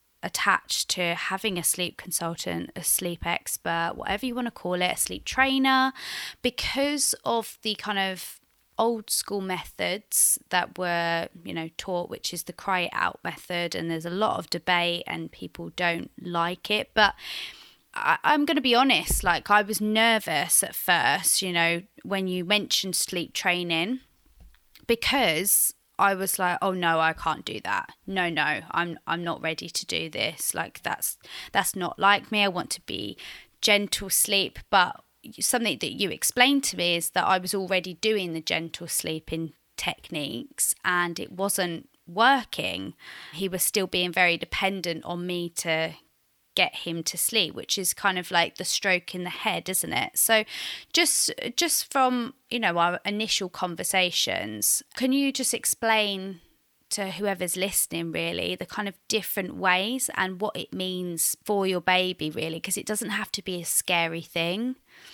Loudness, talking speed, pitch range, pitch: -25 LUFS, 170 wpm, 170-215 Hz, 185 Hz